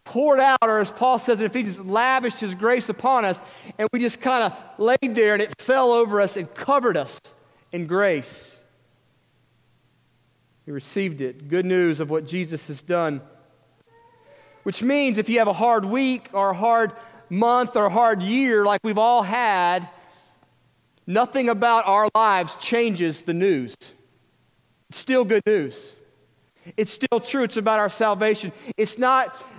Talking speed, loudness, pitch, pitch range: 160 wpm, -21 LUFS, 215 Hz, 170-240 Hz